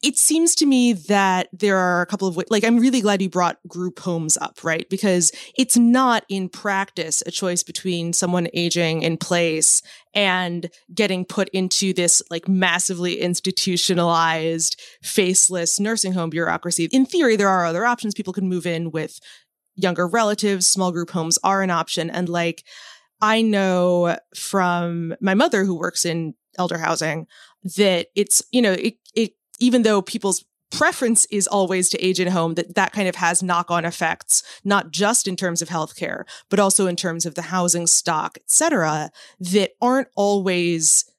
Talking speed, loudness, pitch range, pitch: 175 wpm, -19 LUFS, 170-205 Hz, 185 Hz